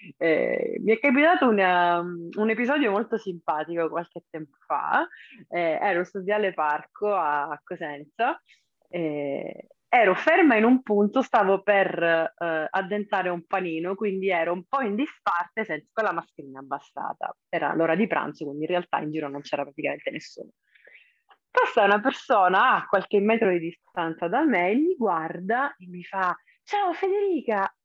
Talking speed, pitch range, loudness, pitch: 155 wpm, 165-225 Hz, -24 LUFS, 190 Hz